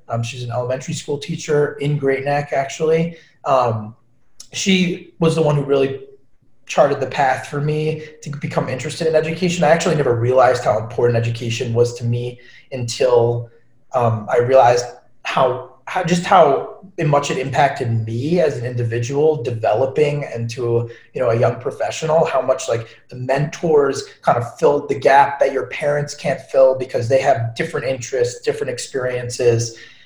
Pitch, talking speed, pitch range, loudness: 140 Hz, 160 wpm, 120-160 Hz, -18 LUFS